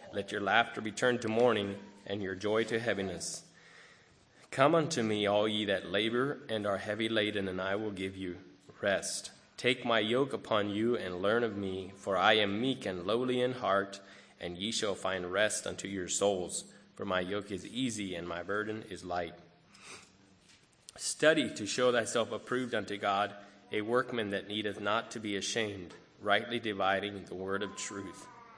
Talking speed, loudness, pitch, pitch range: 180 wpm, -33 LUFS, 105 Hz, 100-115 Hz